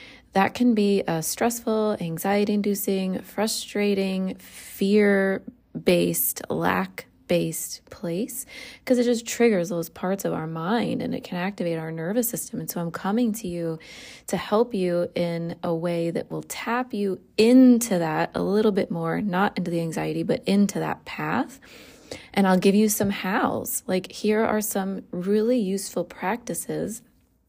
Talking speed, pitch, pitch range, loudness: 155 wpm, 200 Hz, 175-230 Hz, -24 LUFS